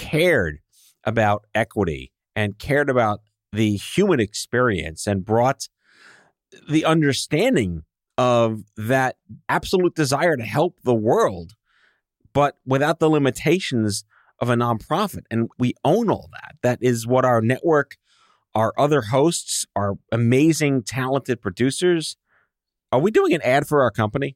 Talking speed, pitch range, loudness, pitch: 130 wpm, 105-140 Hz, -21 LUFS, 120 Hz